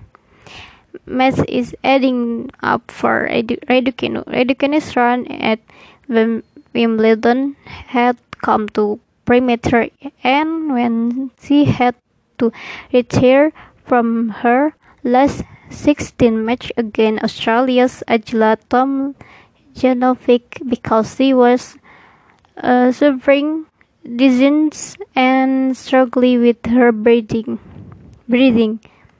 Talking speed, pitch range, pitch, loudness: 80 wpm, 235-265 Hz, 250 Hz, -15 LUFS